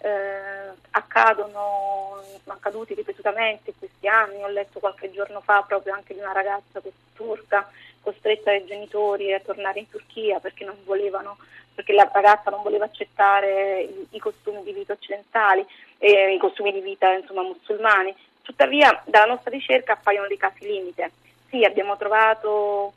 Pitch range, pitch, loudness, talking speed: 195-215 Hz, 205 Hz, -21 LUFS, 155 wpm